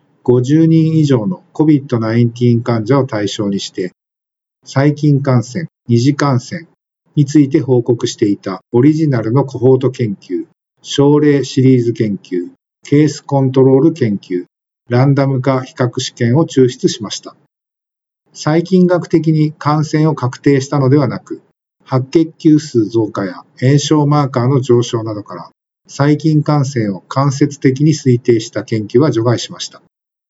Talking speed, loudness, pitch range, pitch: 280 characters per minute, -13 LUFS, 120-150 Hz, 135 Hz